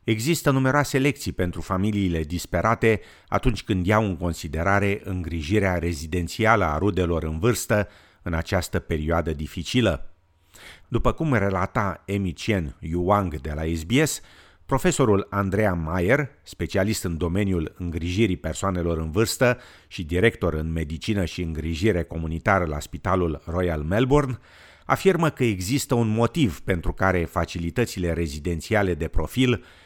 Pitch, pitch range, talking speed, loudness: 95 Hz, 85-110 Hz, 125 wpm, -24 LUFS